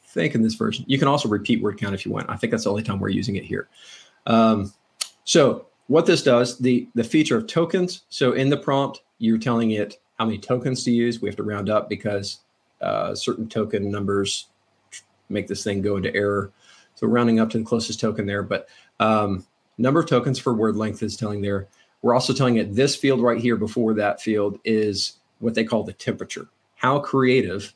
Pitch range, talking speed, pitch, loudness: 105-125 Hz, 215 wpm, 110 Hz, -22 LUFS